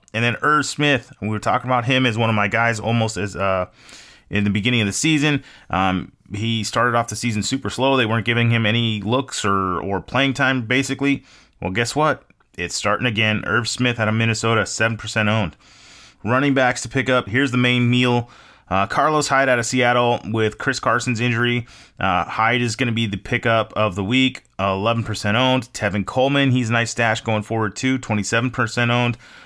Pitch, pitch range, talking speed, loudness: 115 Hz, 110-130 Hz, 205 wpm, -19 LUFS